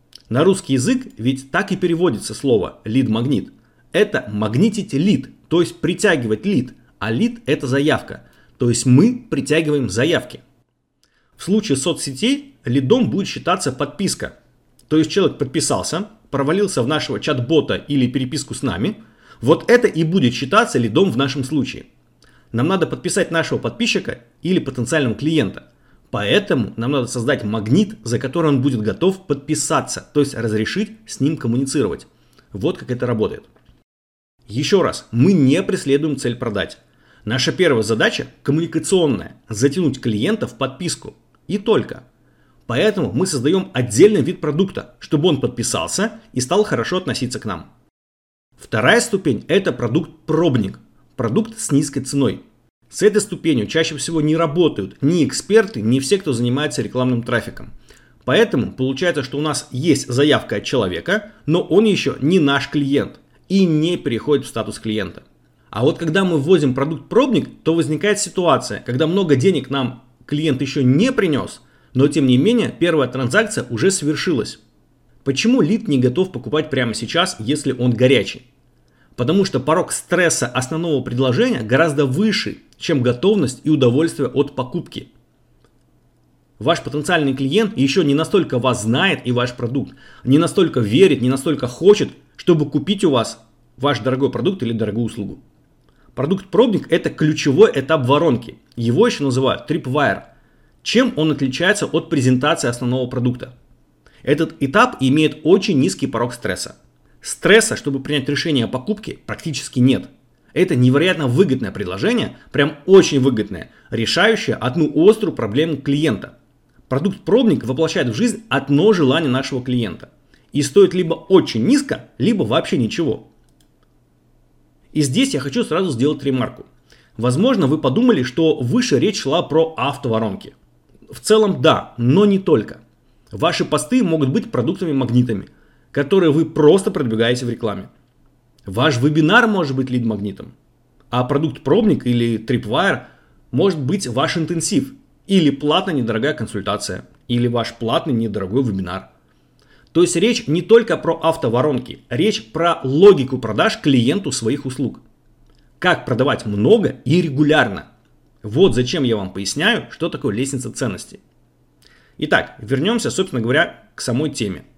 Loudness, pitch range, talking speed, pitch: -18 LUFS, 125-165 Hz, 140 wpm, 140 Hz